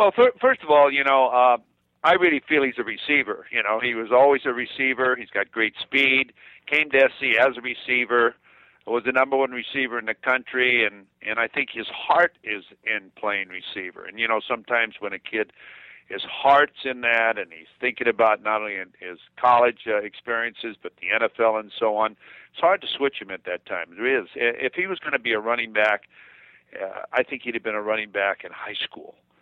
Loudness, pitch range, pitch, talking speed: -22 LUFS, 110-135 Hz, 120 Hz, 220 wpm